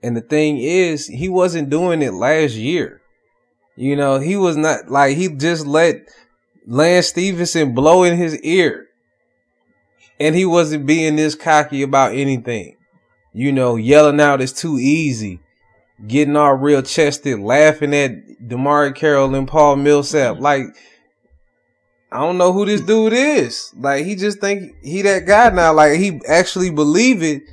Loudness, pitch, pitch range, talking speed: -15 LUFS, 150 Hz, 140-170 Hz, 155 wpm